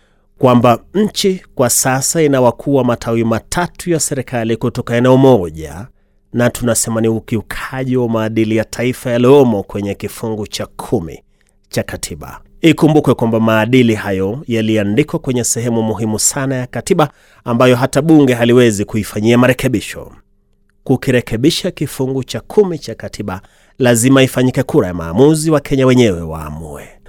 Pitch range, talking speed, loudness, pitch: 110-135 Hz, 130 wpm, -14 LUFS, 120 Hz